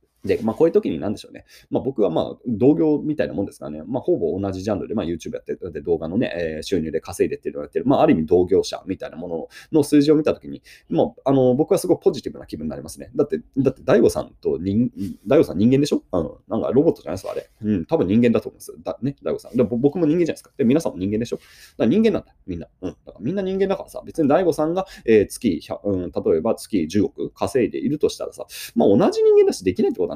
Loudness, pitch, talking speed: -21 LUFS, 195 Hz, 550 characters per minute